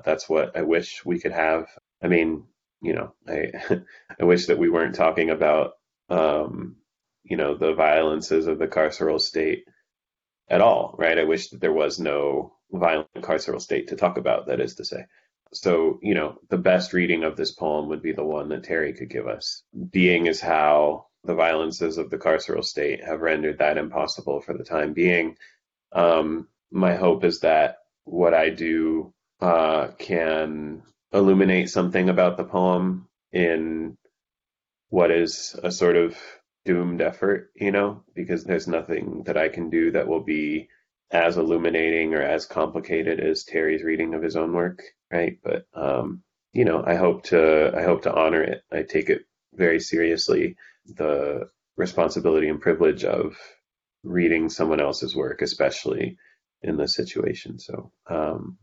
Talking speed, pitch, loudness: 165 wpm, 90 Hz, -23 LUFS